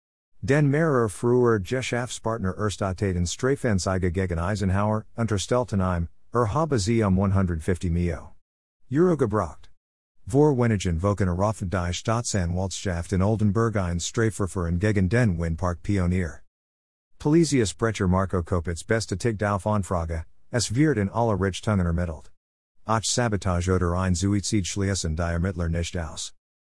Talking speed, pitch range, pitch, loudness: 125 wpm, 85-110 Hz, 100 Hz, -25 LUFS